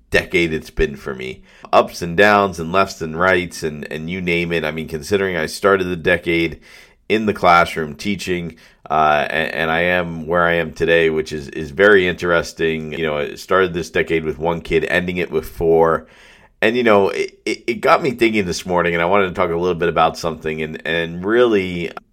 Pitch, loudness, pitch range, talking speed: 85 Hz, -17 LUFS, 80-90 Hz, 215 wpm